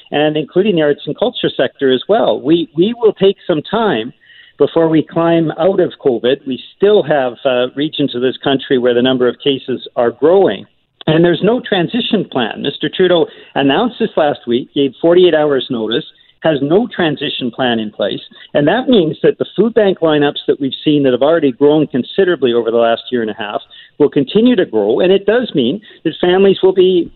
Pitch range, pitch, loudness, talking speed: 135-195 Hz, 155 Hz, -13 LUFS, 205 wpm